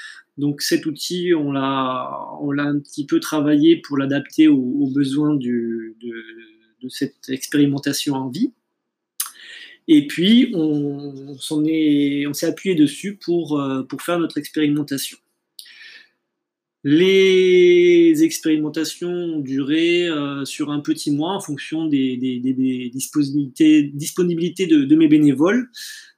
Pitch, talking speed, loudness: 155 Hz, 130 wpm, -19 LUFS